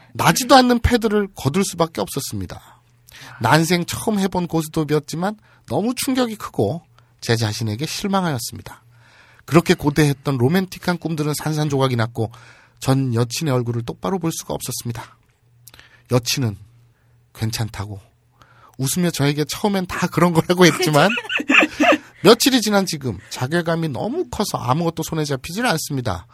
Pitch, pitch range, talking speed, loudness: 150 Hz, 120-180 Hz, 325 characters per minute, -19 LUFS